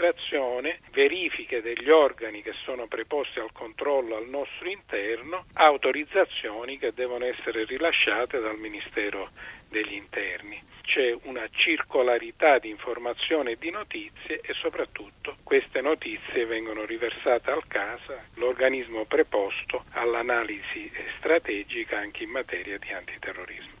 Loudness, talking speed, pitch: -27 LUFS, 115 wpm, 135 Hz